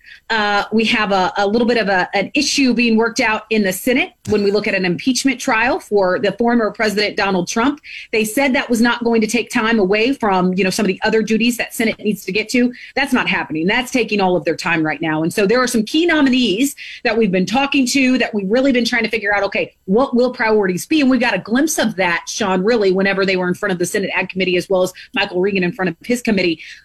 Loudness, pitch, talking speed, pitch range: -16 LUFS, 220 Hz, 265 wpm, 190-245 Hz